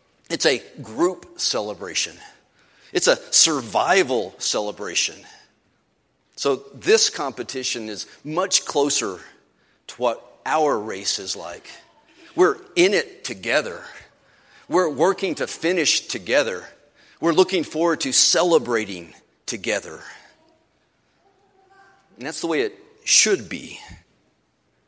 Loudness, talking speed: -21 LUFS, 100 wpm